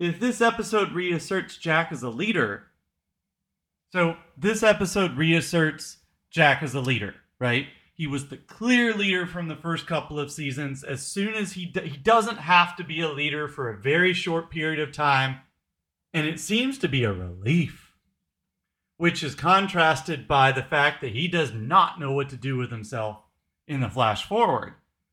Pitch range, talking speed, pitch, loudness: 135-175 Hz, 175 wpm, 155 Hz, -24 LUFS